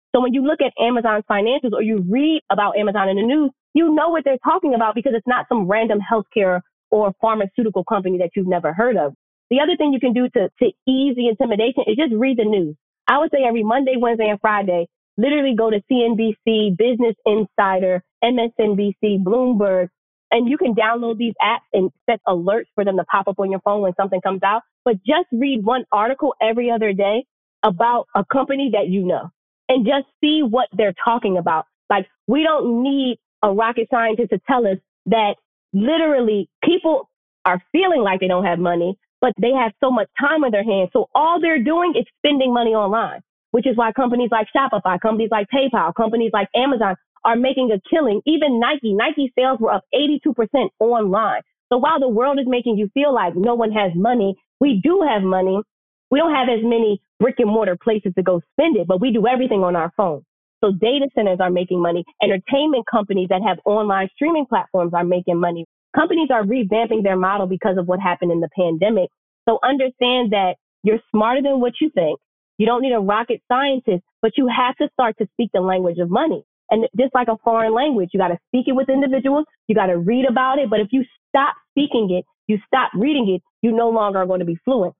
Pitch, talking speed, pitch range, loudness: 225 Hz, 210 wpm, 195-260 Hz, -18 LUFS